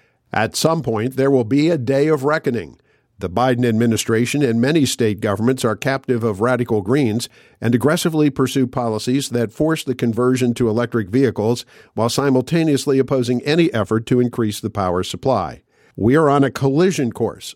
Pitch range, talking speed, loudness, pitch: 115-140 Hz, 165 wpm, -18 LUFS, 125 Hz